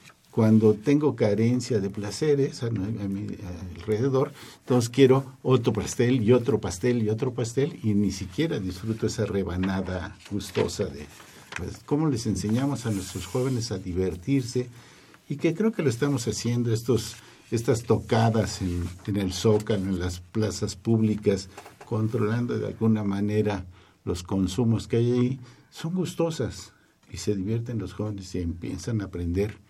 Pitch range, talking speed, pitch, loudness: 100-125 Hz, 150 wpm, 110 Hz, -26 LUFS